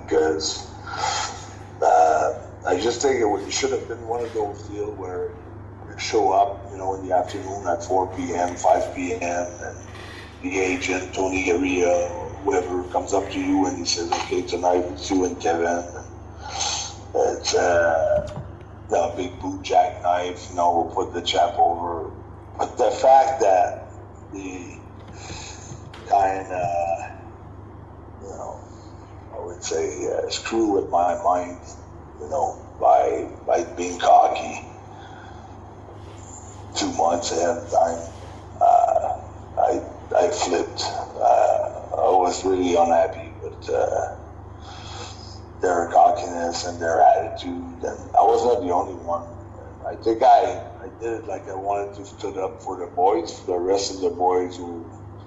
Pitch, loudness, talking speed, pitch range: 95 Hz, -22 LUFS, 140 wpm, 90-105 Hz